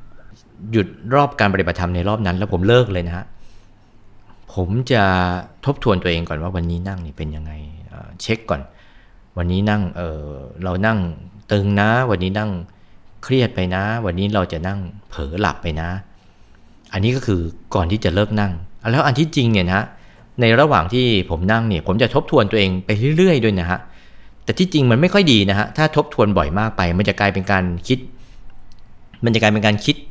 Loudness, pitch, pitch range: -18 LUFS, 100 Hz, 90-115 Hz